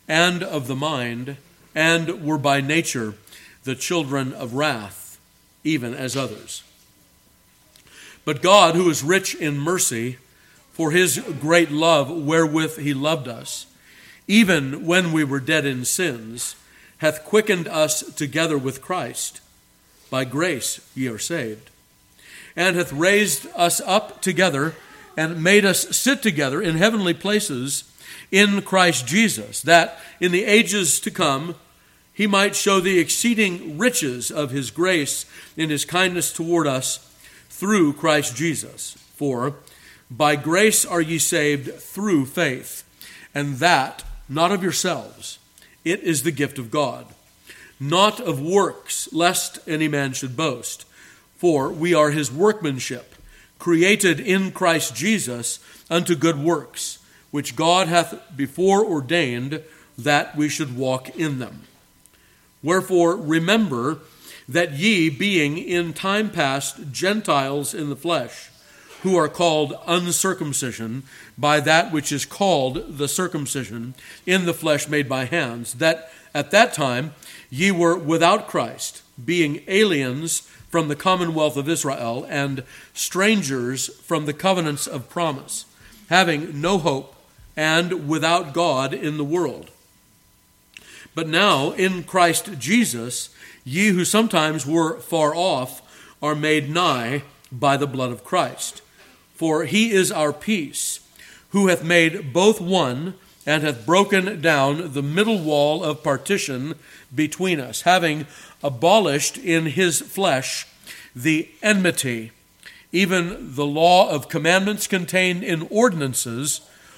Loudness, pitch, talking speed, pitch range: -20 LUFS, 160 Hz, 130 wpm, 140-180 Hz